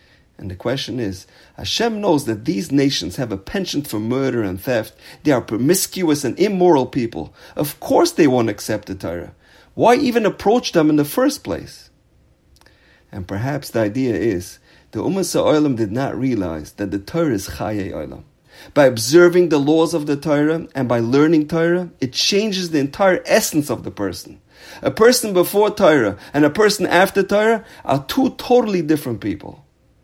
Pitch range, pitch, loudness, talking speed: 130-195 Hz, 155 Hz, -18 LUFS, 175 wpm